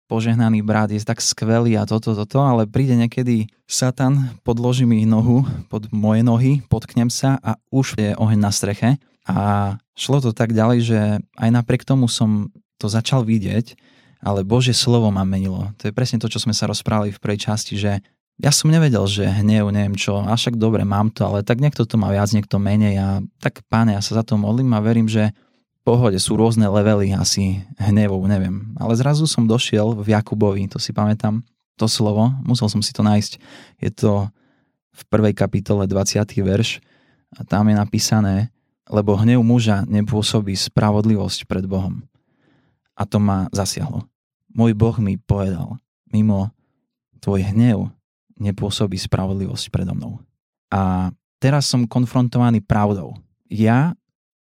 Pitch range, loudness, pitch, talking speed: 105-120 Hz, -19 LUFS, 110 Hz, 165 wpm